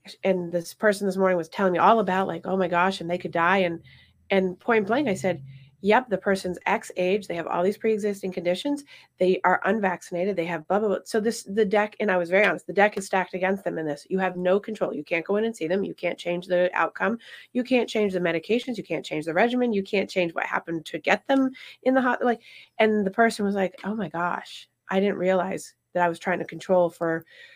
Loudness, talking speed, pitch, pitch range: -25 LUFS, 250 wpm, 190 Hz, 175-210 Hz